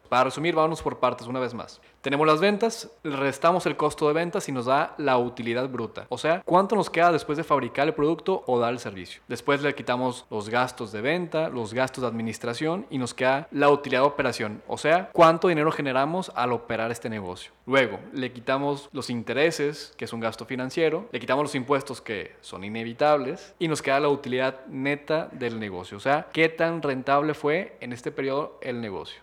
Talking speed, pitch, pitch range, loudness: 205 wpm, 140 Hz, 125-160 Hz, -25 LUFS